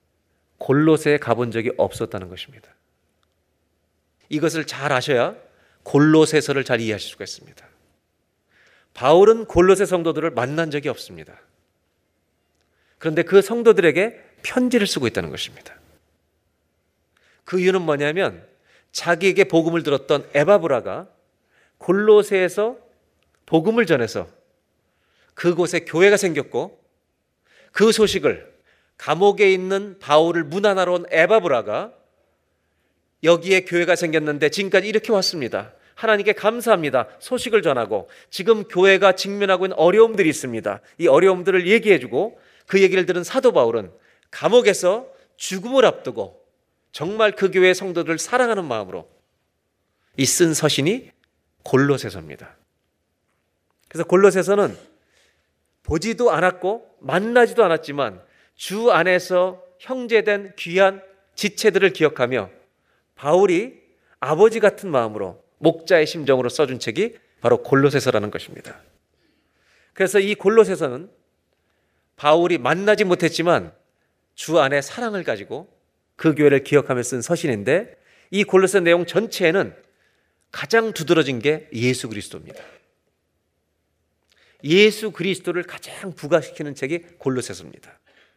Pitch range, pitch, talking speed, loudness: 125-195 Hz, 170 Hz, 290 characters per minute, -19 LUFS